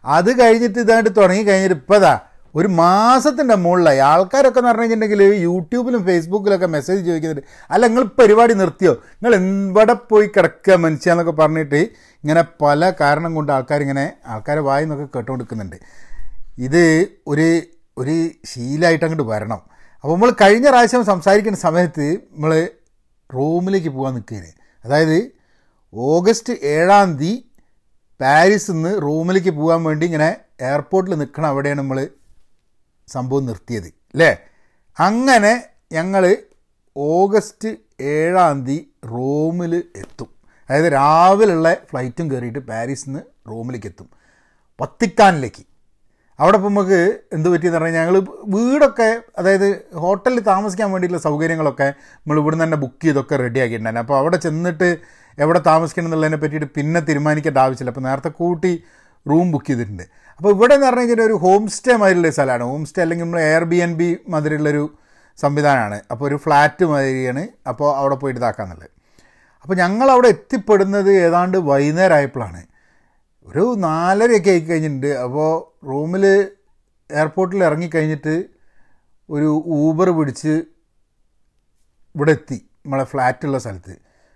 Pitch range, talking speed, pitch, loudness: 140-190 Hz, 120 wpm, 160 Hz, -16 LUFS